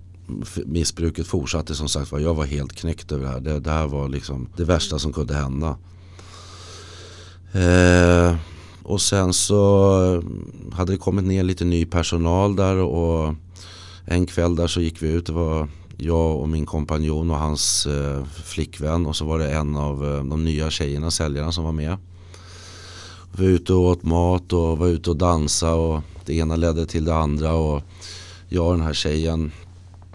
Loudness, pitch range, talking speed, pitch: -21 LUFS, 80-90 Hz, 180 wpm, 85 Hz